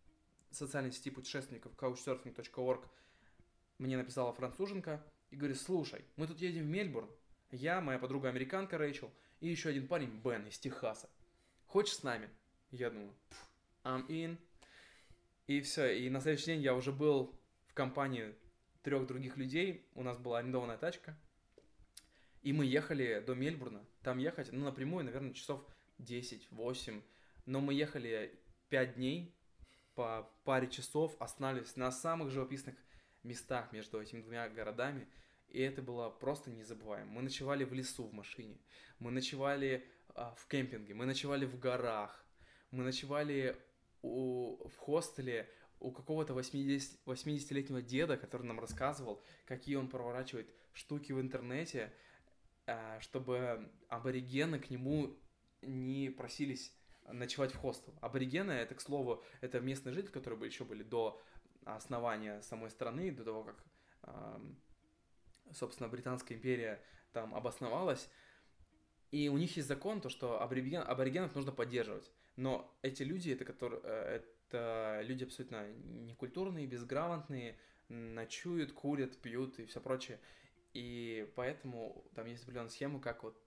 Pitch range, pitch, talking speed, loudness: 120-140 Hz, 130 Hz, 135 wpm, -41 LUFS